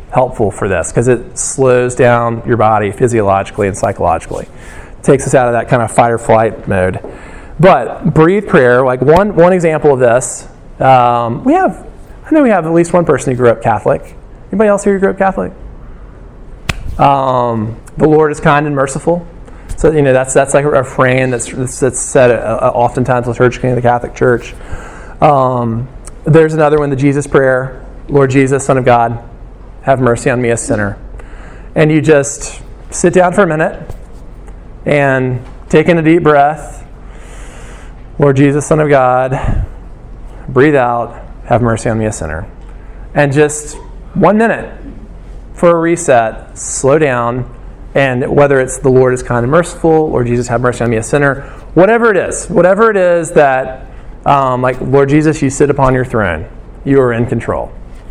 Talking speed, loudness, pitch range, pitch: 175 wpm, -11 LUFS, 120-155 Hz, 130 Hz